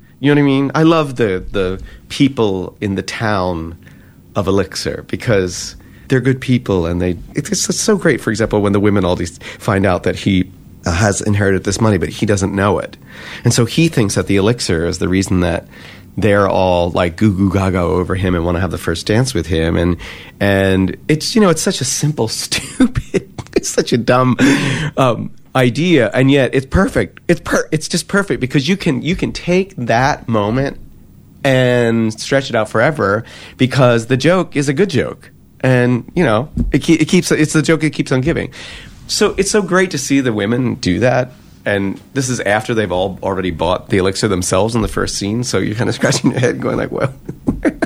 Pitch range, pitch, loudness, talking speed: 95-140 Hz, 115 Hz, -15 LUFS, 210 wpm